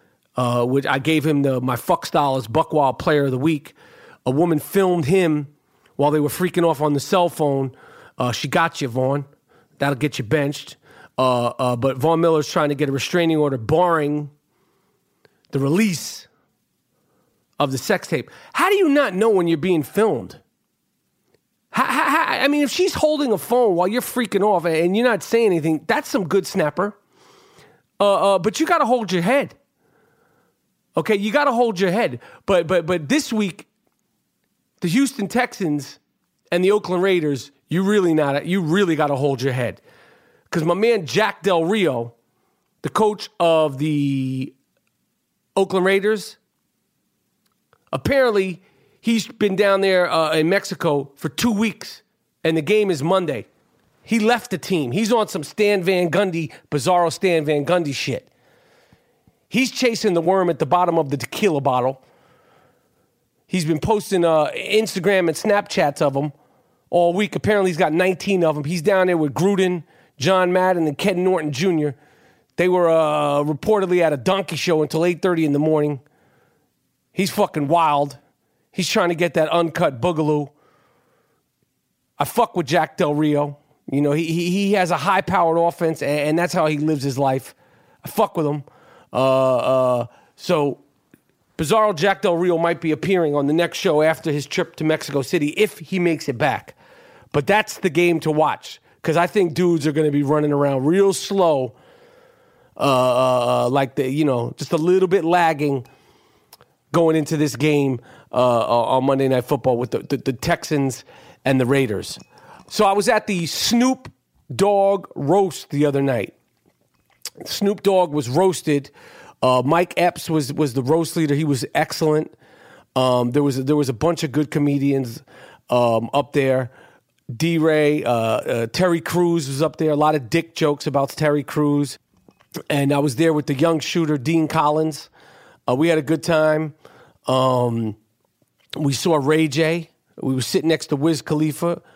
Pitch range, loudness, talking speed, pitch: 145-185 Hz, -19 LUFS, 175 wpm, 160 Hz